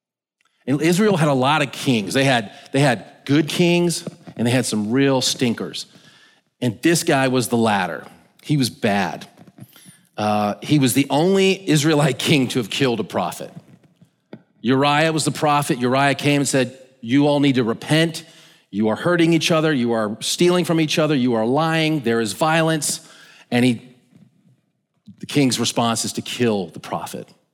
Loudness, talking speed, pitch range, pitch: -19 LUFS, 175 wpm, 125-160 Hz, 140 Hz